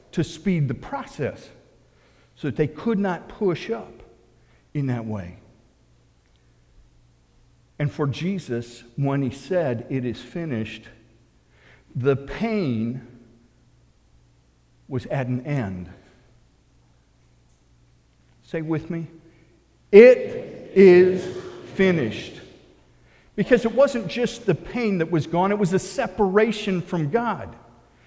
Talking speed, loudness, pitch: 105 wpm, -22 LUFS, 135 Hz